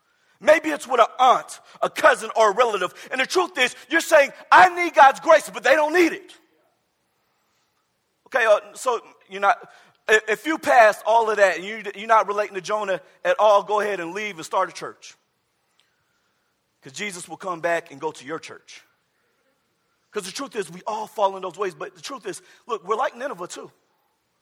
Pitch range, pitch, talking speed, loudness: 195-290 Hz, 215 Hz, 195 wpm, -20 LUFS